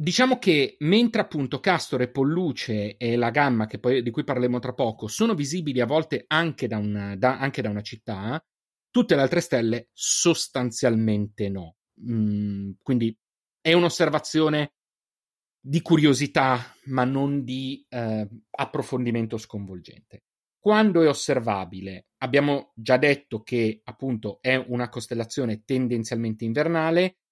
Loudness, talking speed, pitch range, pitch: -24 LUFS, 130 wpm, 110-150 Hz, 125 Hz